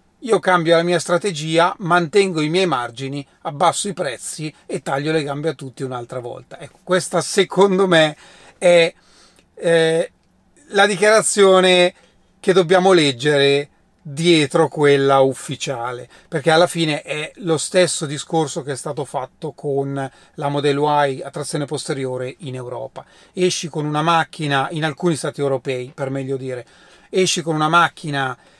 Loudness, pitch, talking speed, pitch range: -18 LUFS, 160 Hz, 145 wpm, 140-175 Hz